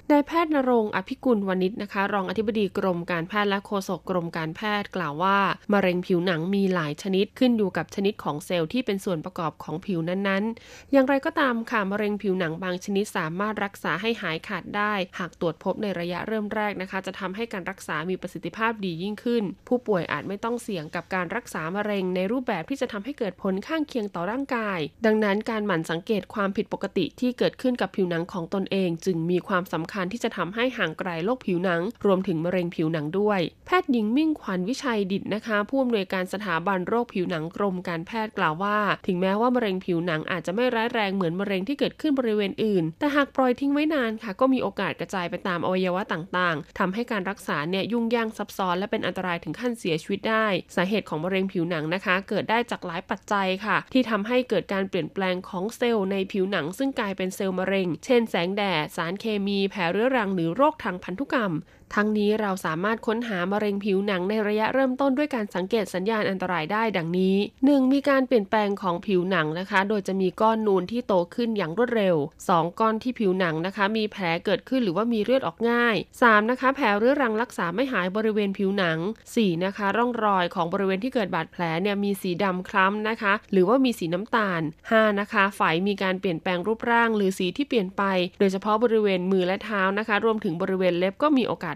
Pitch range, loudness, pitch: 180-225 Hz, -25 LUFS, 200 Hz